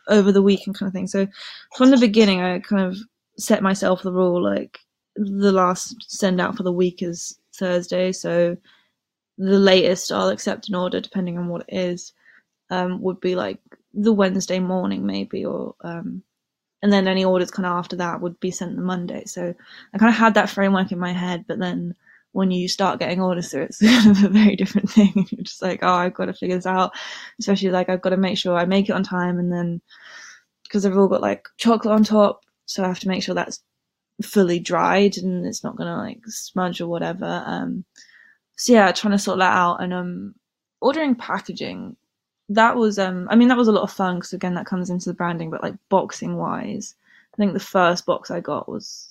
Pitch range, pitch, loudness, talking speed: 180-210 Hz, 190 Hz, -20 LUFS, 220 wpm